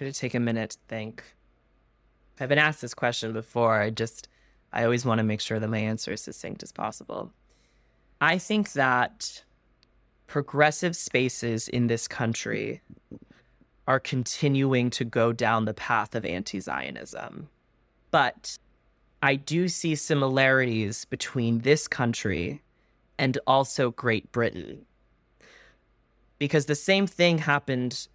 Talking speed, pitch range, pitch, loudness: 130 wpm, 110-145 Hz, 125 Hz, -26 LUFS